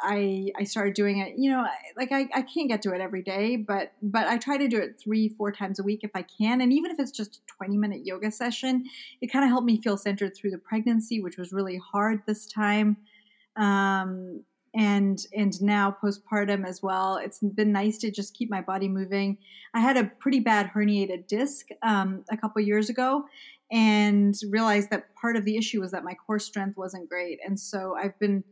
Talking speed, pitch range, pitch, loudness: 220 wpm, 195-225 Hz, 210 Hz, -27 LUFS